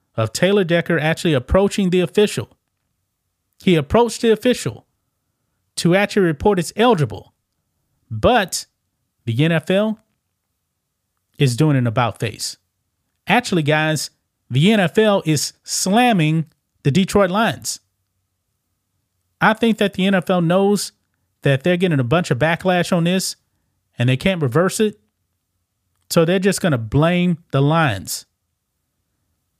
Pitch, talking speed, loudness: 155 Hz, 120 wpm, -18 LUFS